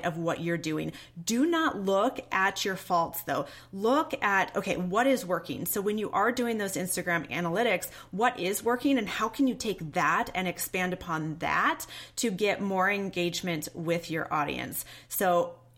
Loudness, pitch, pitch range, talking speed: -29 LUFS, 185 Hz, 170-210 Hz, 175 wpm